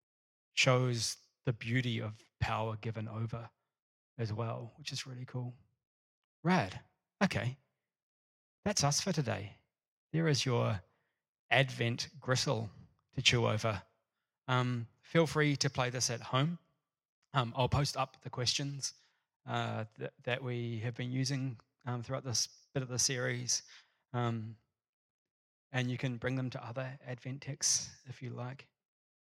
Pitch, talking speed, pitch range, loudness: 125 Hz, 140 wpm, 115-135 Hz, -35 LUFS